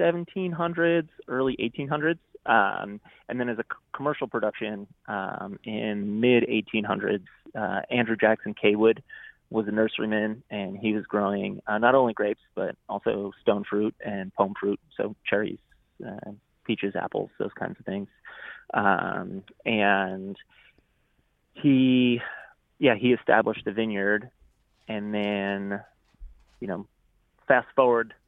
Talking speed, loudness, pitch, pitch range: 125 wpm, -26 LUFS, 110 Hz, 105-125 Hz